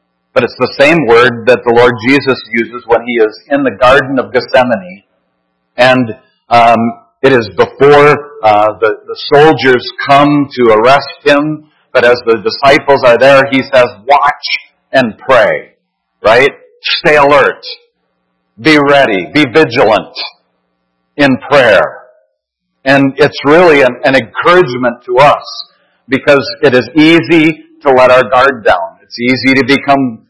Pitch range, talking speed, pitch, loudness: 115-145 Hz, 145 wpm, 135 Hz, -8 LUFS